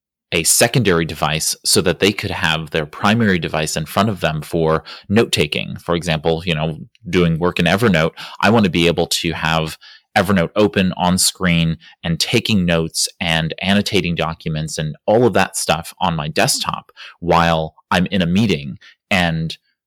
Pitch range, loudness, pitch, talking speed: 80-90 Hz, -17 LUFS, 85 Hz, 170 wpm